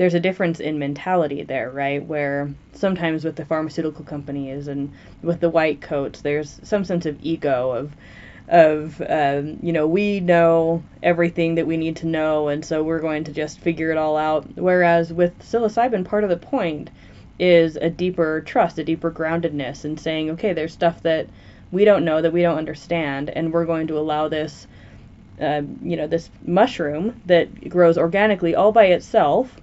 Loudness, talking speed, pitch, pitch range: -20 LUFS, 180 wpm, 160 Hz, 150-170 Hz